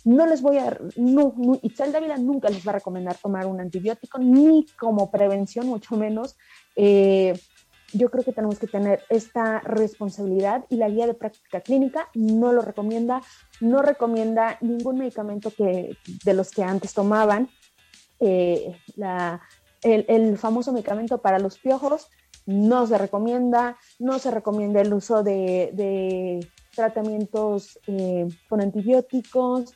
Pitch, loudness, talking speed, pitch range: 220 Hz, -22 LUFS, 145 wpm, 200-245 Hz